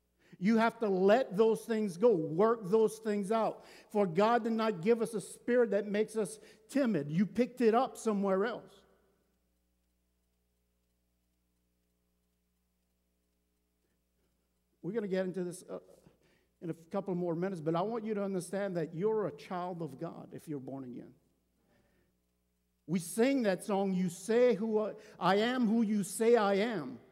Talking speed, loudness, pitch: 155 wpm, -32 LUFS, 190 Hz